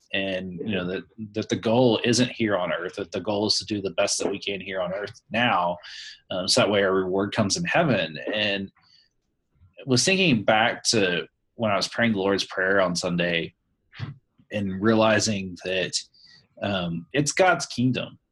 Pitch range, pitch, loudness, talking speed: 95-115 Hz, 100 Hz, -24 LUFS, 185 wpm